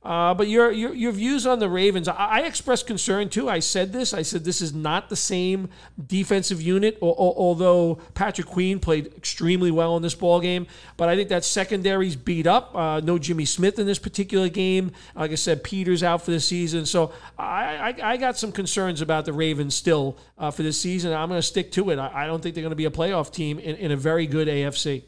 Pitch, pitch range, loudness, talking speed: 175 Hz, 160-195 Hz, -23 LUFS, 235 wpm